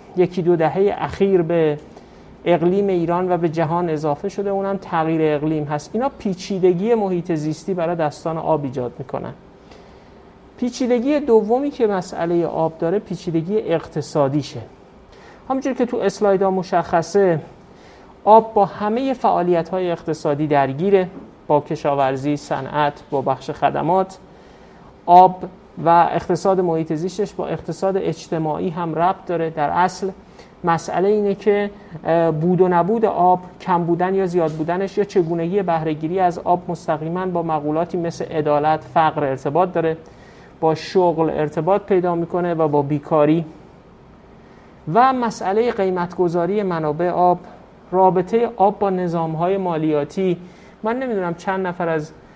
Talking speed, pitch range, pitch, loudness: 130 wpm, 160-195 Hz, 175 Hz, -19 LUFS